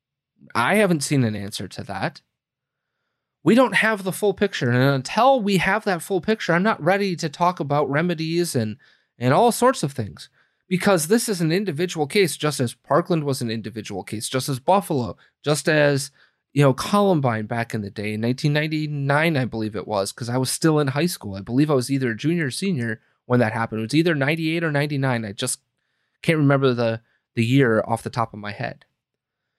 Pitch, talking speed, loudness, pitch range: 145 Hz, 205 wpm, -21 LUFS, 120-175 Hz